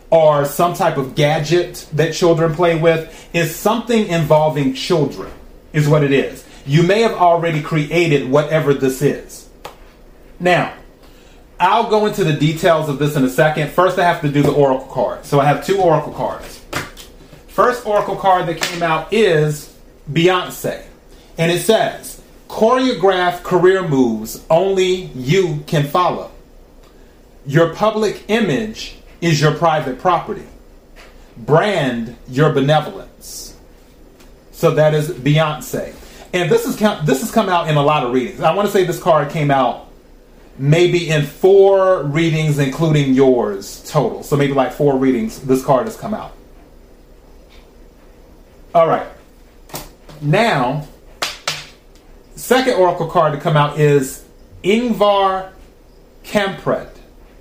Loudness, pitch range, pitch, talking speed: -16 LUFS, 140-180 Hz, 160 Hz, 135 wpm